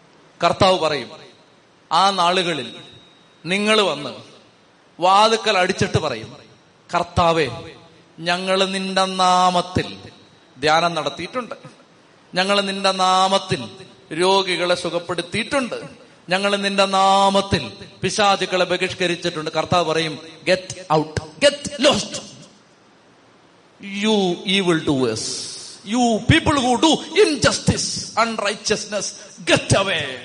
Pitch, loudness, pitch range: 185 Hz, -19 LUFS, 170-200 Hz